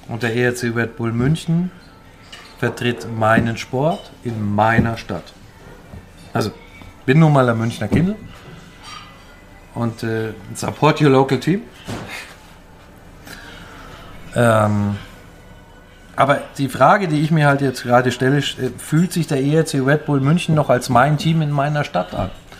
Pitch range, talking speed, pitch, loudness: 100-140 Hz, 135 wpm, 120 Hz, -18 LUFS